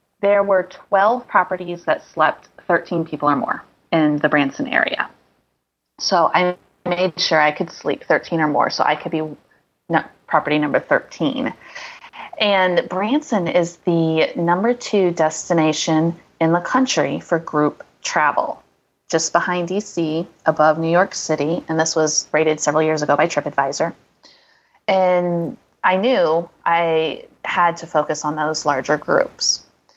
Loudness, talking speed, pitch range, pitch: -19 LUFS, 140 wpm, 155-185 Hz, 170 Hz